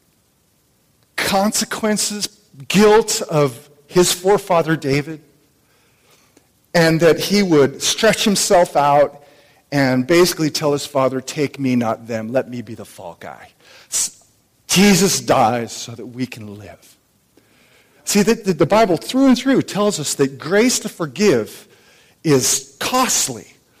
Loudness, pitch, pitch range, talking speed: -16 LUFS, 155 Hz, 135-200 Hz, 130 wpm